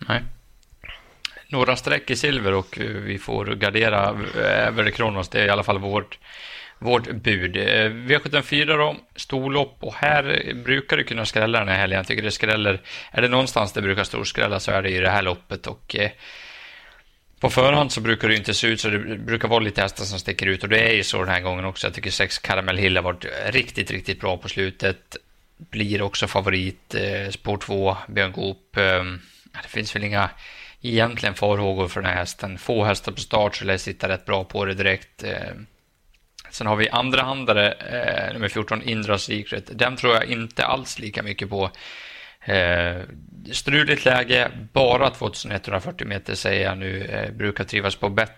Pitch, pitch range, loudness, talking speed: 105 Hz, 95-115 Hz, -22 LUFS, 185 wpm